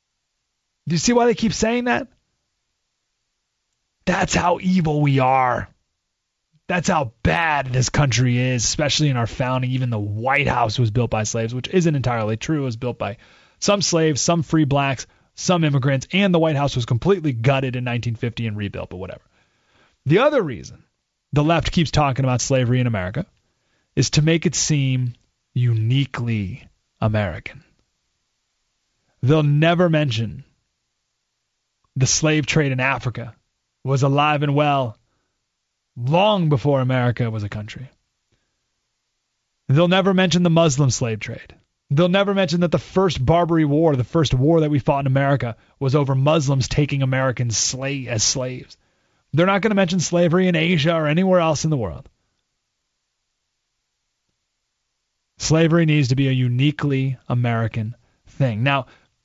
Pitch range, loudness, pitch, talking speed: 120-160 Hz, -19 LUFS, 135 Hz, 150 wpm